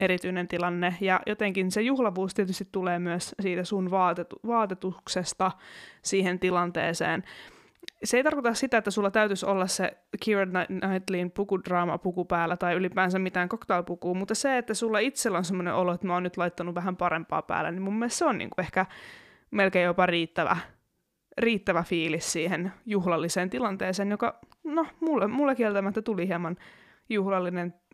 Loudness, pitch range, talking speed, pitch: -28 LUFS, 180-210 Hz, 160 wpm, 185 Hz